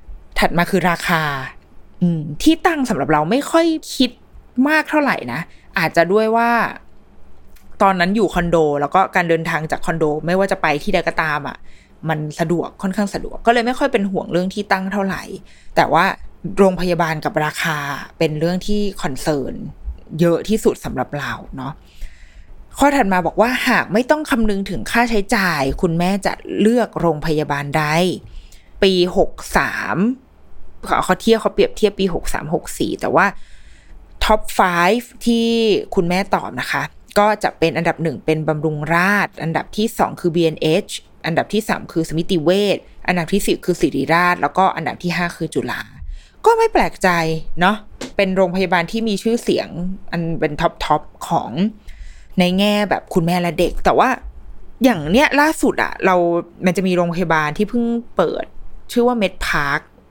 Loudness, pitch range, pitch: -18 LUFS, 160-210 Hz, 180 Hz